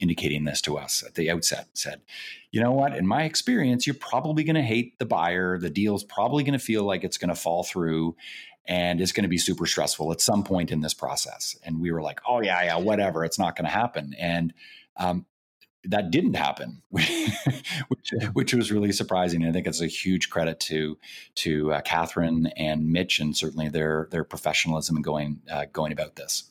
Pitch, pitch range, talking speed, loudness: 85 Hz, 80-105 Hz, 215 wpm, -26 LUFS